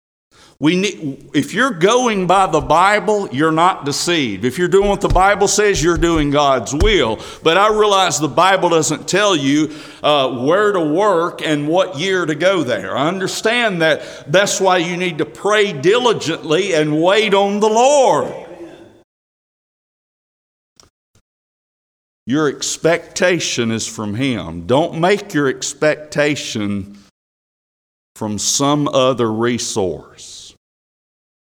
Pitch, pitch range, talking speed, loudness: 165 Hz, 145-195 Hz, 130 wpm, -15 LUFS